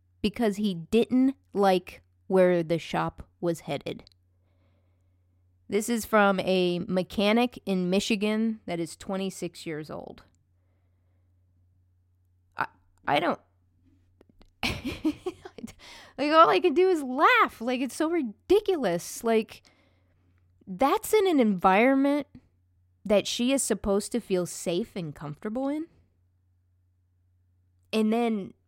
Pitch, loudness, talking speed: 180 Hz, -26 LUFS, 110 wpm